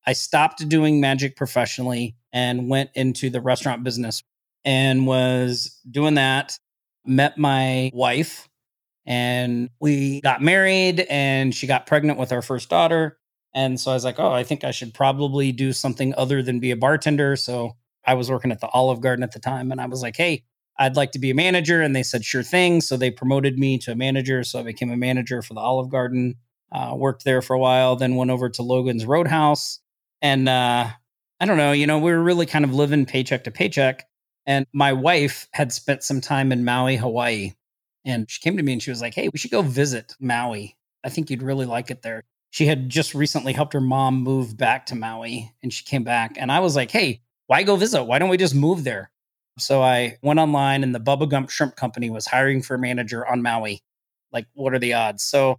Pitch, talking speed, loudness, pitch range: 130 Hz, 220 wpm, -21 LUFS, 125-140 Hz